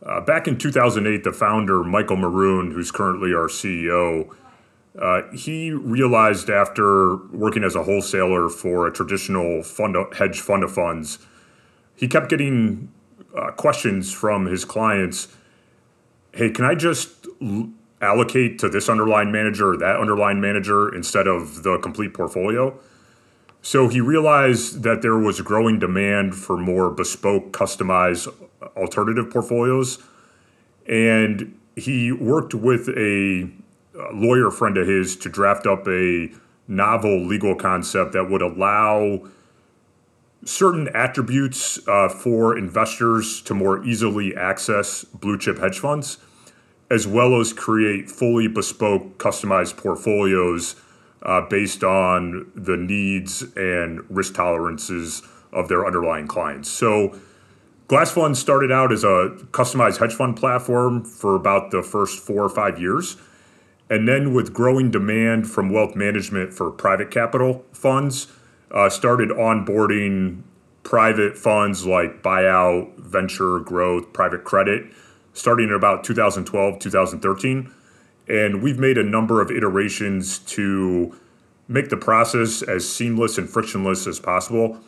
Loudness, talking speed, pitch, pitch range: -20 LUFS, 130 wpm, 105 Hz, 95-120 Hz